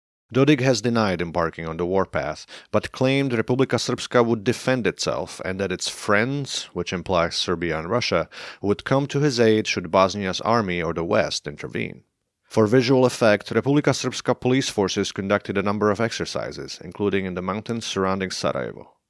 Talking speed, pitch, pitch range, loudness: 165 wpm, 105 Hz, 95-125 Hz, -22 LUFS